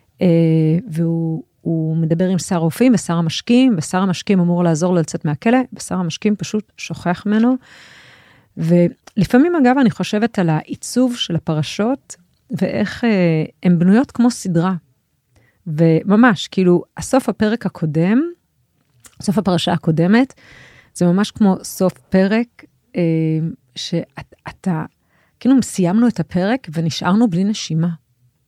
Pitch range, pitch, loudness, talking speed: 165-220 Hz, 180 Hz, -17 LUFS, 120 wpm